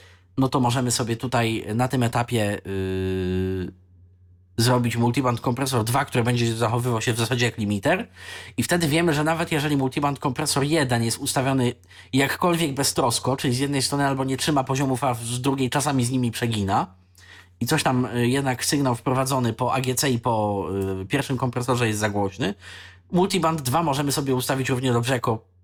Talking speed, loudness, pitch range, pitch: 170 wpm, -23 LUFS, 110-140 Hz, 125 Hz